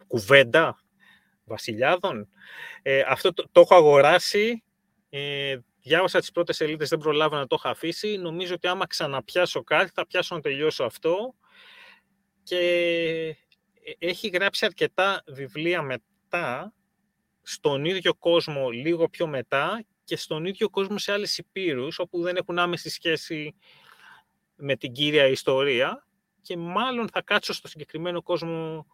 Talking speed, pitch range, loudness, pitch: 135 wpm, 155-195 Hz, -24 LUFS, 175 Hz